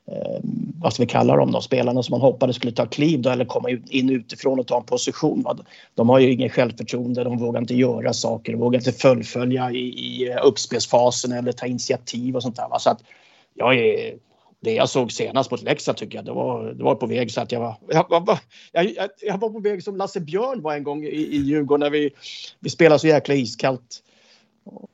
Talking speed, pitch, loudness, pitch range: 220 wpm, 130 Hz, -21 LUFS, 125-150 Hz